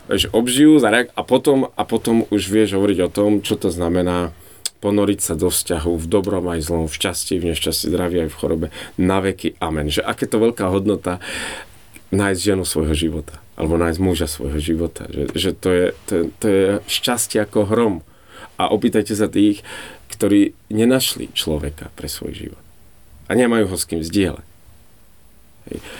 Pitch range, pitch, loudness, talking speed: 85-105 Hz, 95 Hz, -19 LUFS, 170 wpm